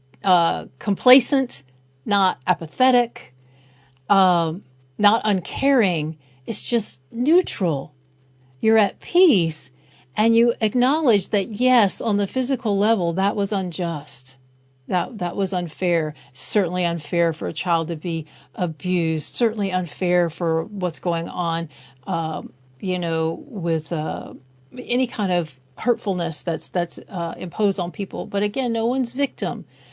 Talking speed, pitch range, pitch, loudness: 130 wpm, 160-215 Hz, 180 Hz, -22 LUFS